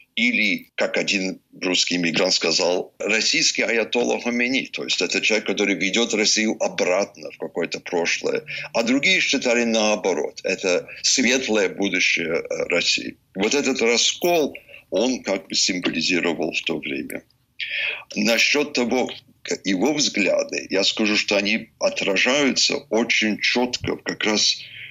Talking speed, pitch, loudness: 125 wpm, 120 Hz, -20 LUFS